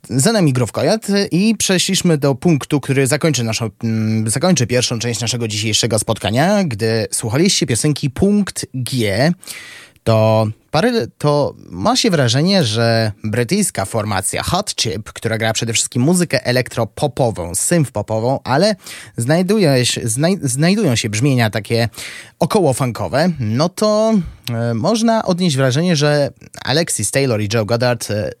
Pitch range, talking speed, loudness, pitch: 115-170 Hz, 130 wpm, -16 LUFS, 130 Hz